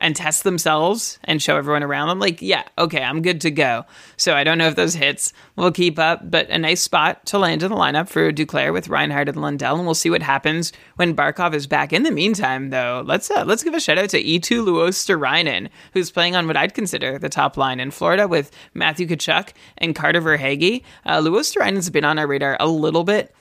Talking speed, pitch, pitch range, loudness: 230 wpm, 165 Hz, 150-180 Hz, -18 LUFS